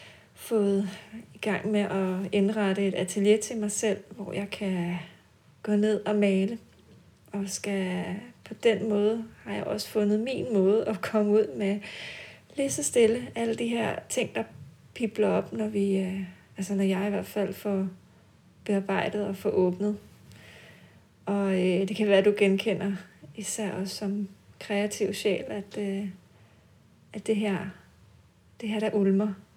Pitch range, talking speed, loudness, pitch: 190-210 Hz, 155 wpm, -28 LUFS, 200 Hz